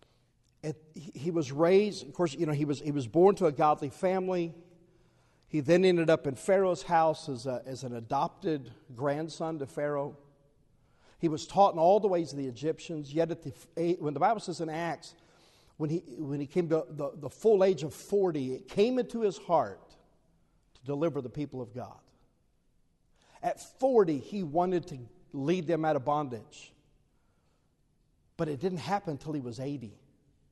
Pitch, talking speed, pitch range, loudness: 155 Hz, 180 wpm, 140-175 Hz, -30 LUFS